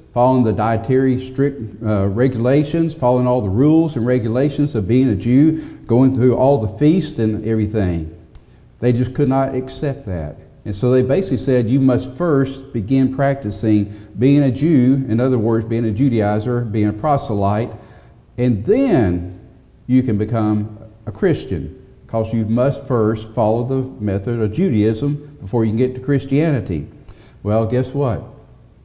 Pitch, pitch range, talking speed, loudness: 125 Hz, 110-135 Hz, 160 wpm, -17 LUFS